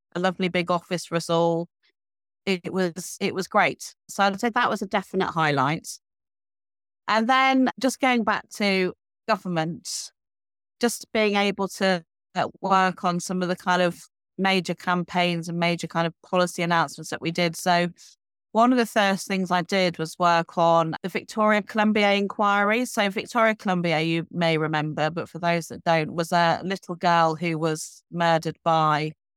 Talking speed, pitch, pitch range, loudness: 170 wpm, 180 Hz, 165-200 Hz, -24 LUFS